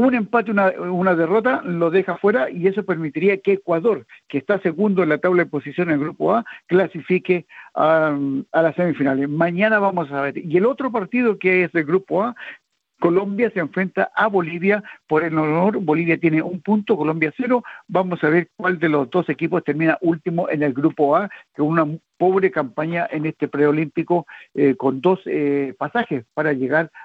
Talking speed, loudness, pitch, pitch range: 185 wpm, -20 LUFS, 175 Hz, 155-190 Hz